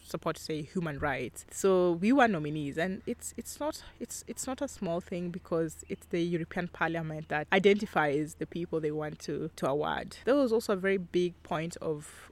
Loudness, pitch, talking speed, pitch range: -32 LUFS, 175 Hz, 195 wpm, 155-195 Hz